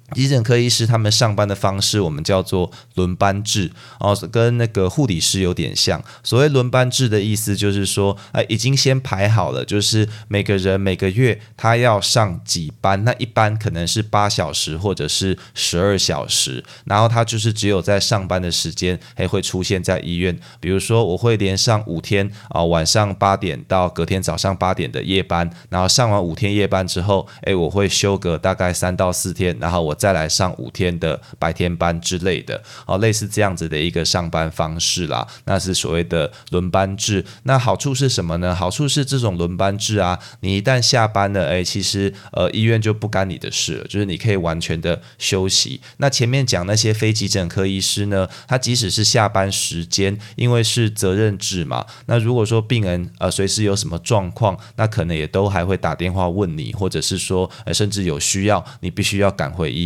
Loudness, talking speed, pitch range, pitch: -18 LUFS, 300 characters per minute, 90-110 Hz, 100 Hz